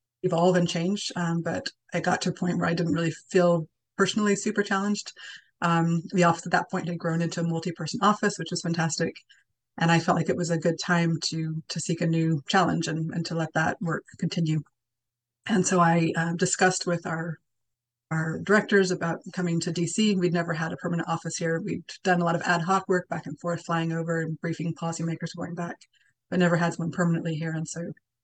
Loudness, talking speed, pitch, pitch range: -26 LUFS, 215 wpm, 170 Hz, 165-180 Hz